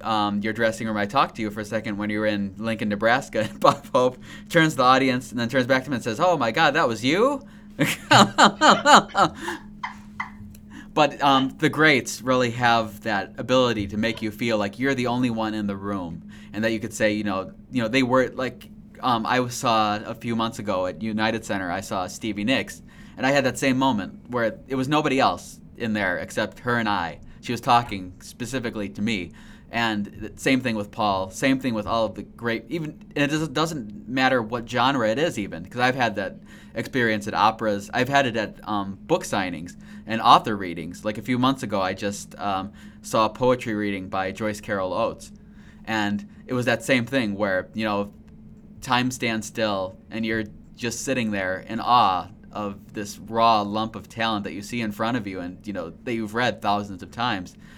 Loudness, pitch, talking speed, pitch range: -23 LUFS, 110 Hz, 210 wpm, 105-125 Hz